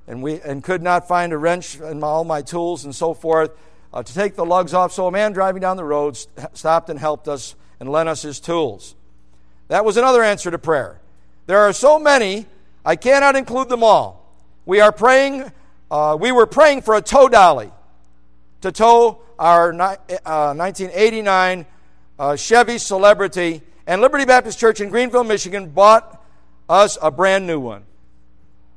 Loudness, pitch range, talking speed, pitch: -16 LUFS, 150-210 Hz, 180 wpm, 175 Hz